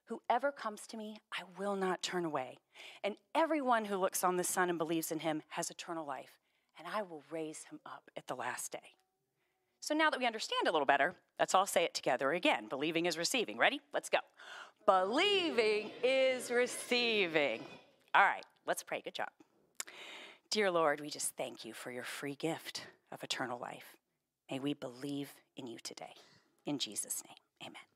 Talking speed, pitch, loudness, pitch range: 180 wpm, 190 Hz, -35 LUFS, 165-260 Hz